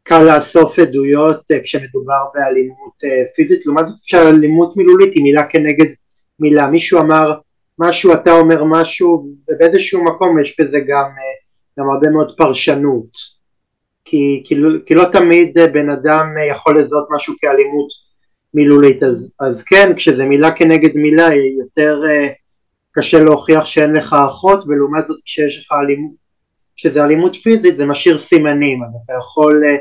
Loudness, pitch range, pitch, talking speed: -11 LUFS, 140-165 Hz, 150 Hz, 140 wpm